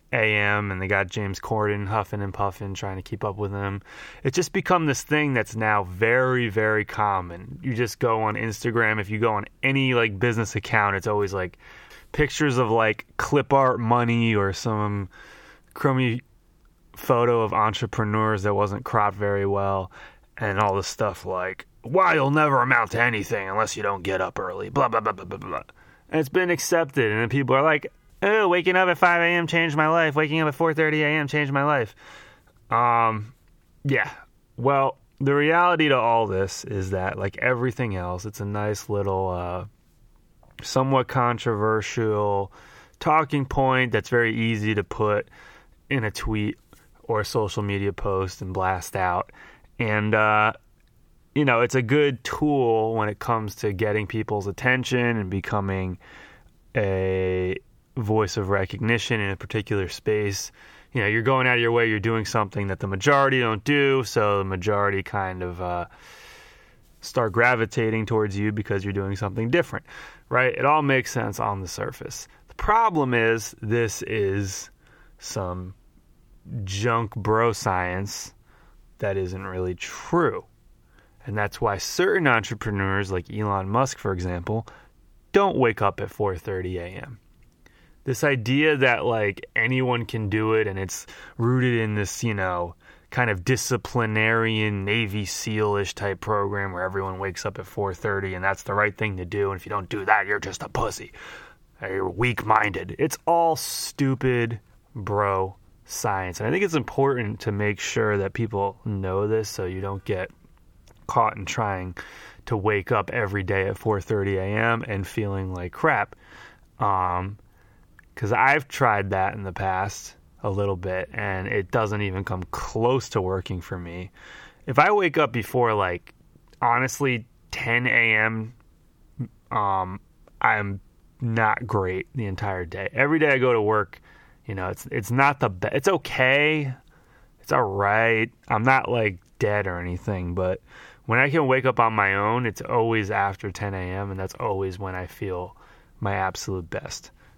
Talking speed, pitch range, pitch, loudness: 165 wpm, 100-120 Hz, 105 Hz, -24 LUFS